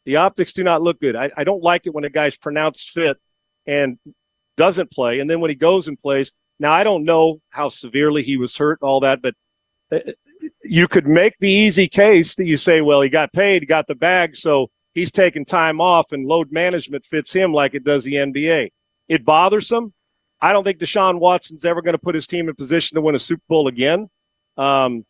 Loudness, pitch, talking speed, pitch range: -17 LUFS, 160 Hz, 225 wpm, 145-180 Hz